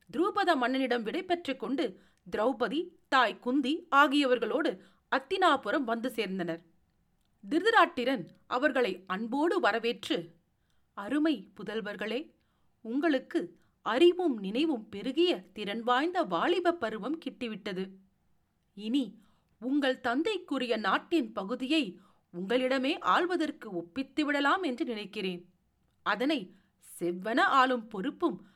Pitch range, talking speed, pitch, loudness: 210-310 Hz, 85 wpm, 255 Hz, -30 LUFS